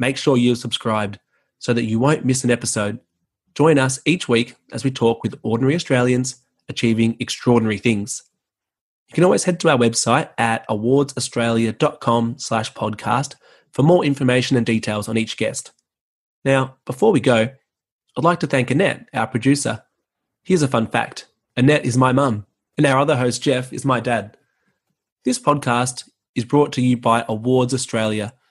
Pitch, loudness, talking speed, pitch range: 125 Hz, -19 LUFS, 160 wpm, 115-135 Hz